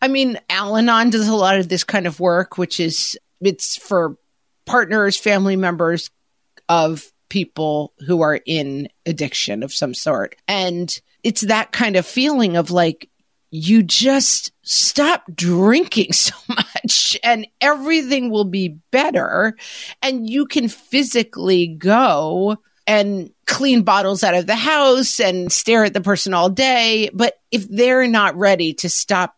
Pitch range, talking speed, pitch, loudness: 175-240 Hz, 145 wpm, 205 Hz, -17 LUFS